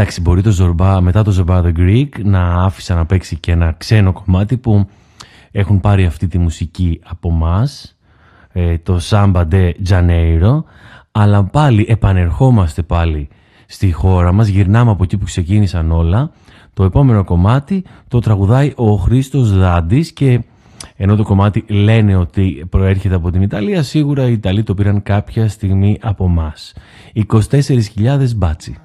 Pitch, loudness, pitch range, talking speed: 100 Hz, -13 LUFS, 90-110 Hz, 150 wpm